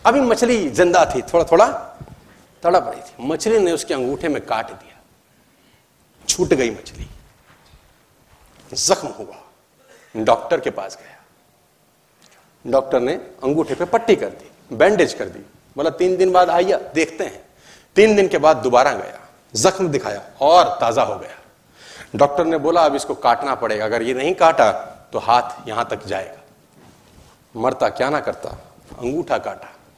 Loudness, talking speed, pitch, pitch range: -18 LUFS, 150 wpm, 180 Hz, 160-210 Hz